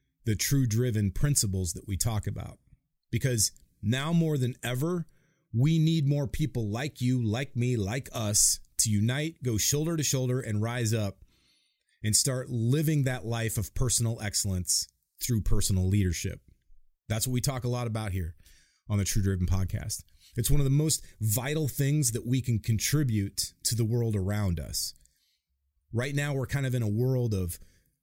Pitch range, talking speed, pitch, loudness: 100-135 Hz, 175 wpm, 115 Hz, -28 LUFS